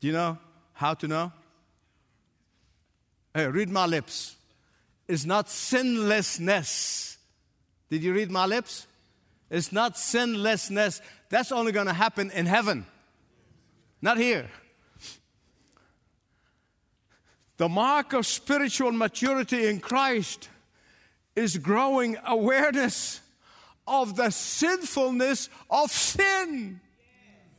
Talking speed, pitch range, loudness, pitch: 100 wpm, 180-255 Hz, -26 LUFS, 215 Hz